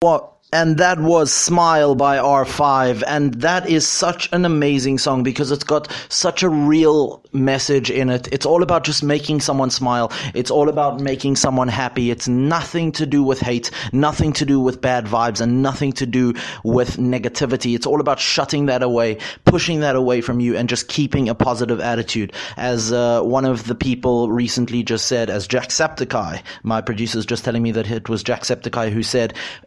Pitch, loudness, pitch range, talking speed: 130 Hz, -18 LUFS, 120-145 Hz, 205 wpm